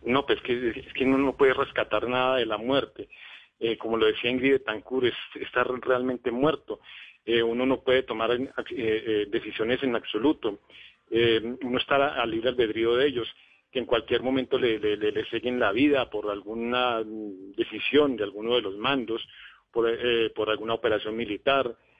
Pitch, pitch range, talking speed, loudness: 120 Hz, 110-130 Hz, 180 wpm, -26 LUFS